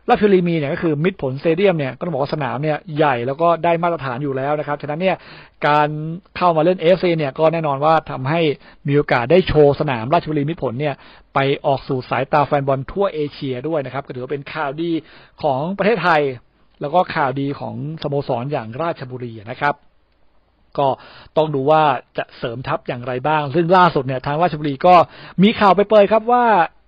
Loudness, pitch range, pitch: -18 LUFS, 140-170 Hz, 150 Hz